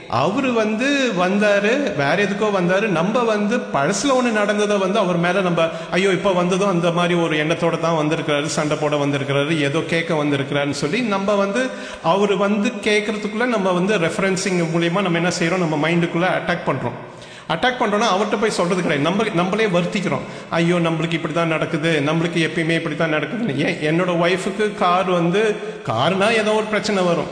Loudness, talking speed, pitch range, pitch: -19 LUFS, 165 wpm, 165-210 Hz, 180 Hz